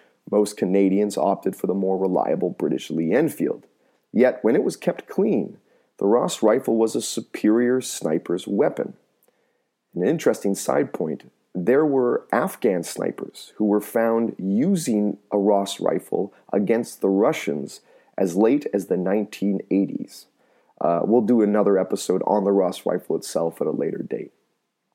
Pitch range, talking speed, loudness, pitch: 95-110 Hz, 145 wpm, -22 LUFS, 105 Hz